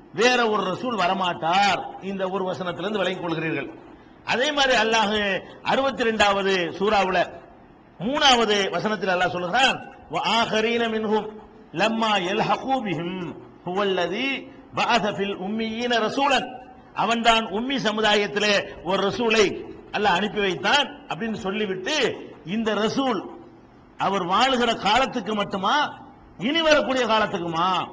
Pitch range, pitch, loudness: 195-240 Hz, 215 Hz, -22 LUFS